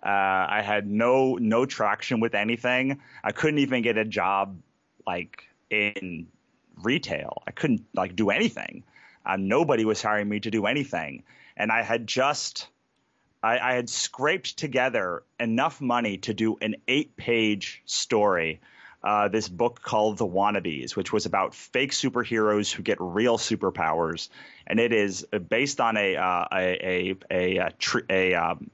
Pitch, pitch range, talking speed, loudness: 105 Hz, 95-120 Hz, 155 wpm, -26 LUFS